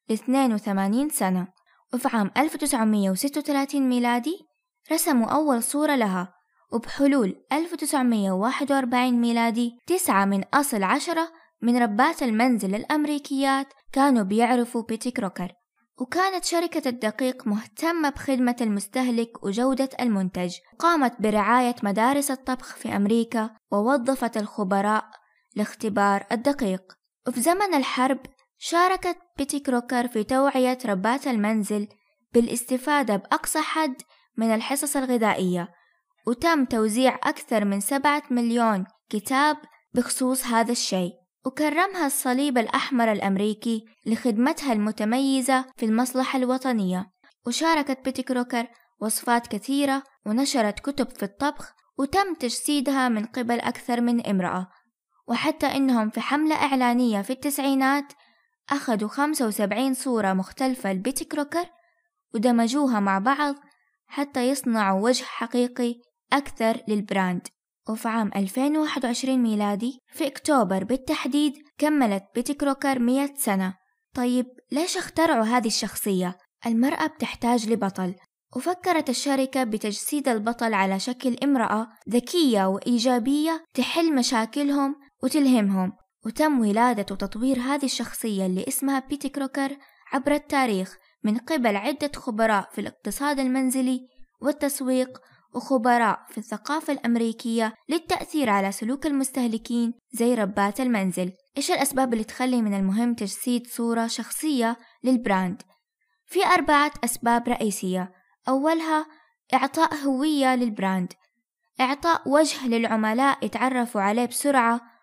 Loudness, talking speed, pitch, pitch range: -24 LUFS, 105 wpm, 250 Hz, 220-280 Hz